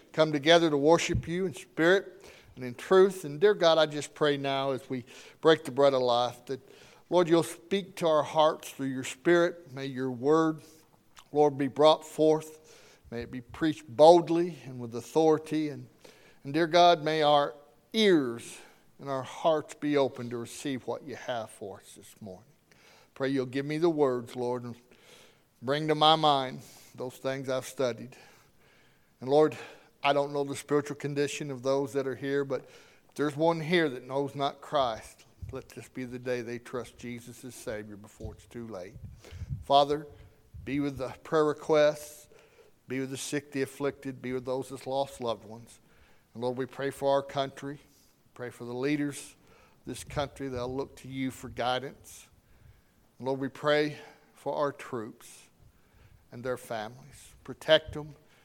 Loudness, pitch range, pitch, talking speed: -28 LUFS, 125-155 Hz, 140 Hz, 180 wpm